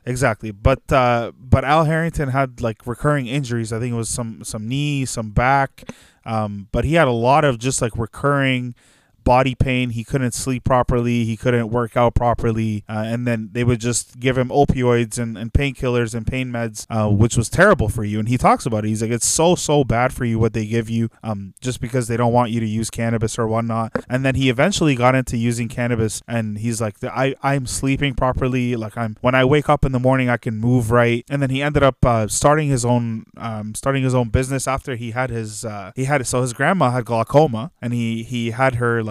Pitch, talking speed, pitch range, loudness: 120 Hz, 230 wpm, 115-130 Hz, -19 LUFS